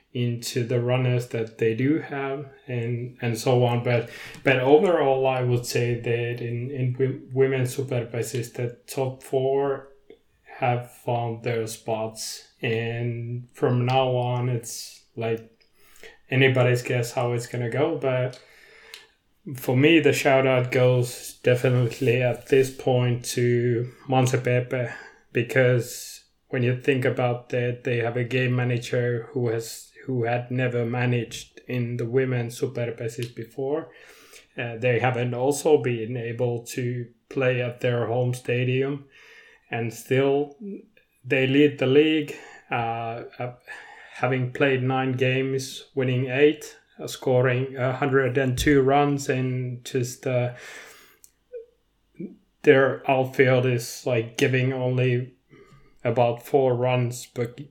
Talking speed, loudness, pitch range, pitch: 125 wpm, -24 LUFS, 120-135 Hz, 125 Hz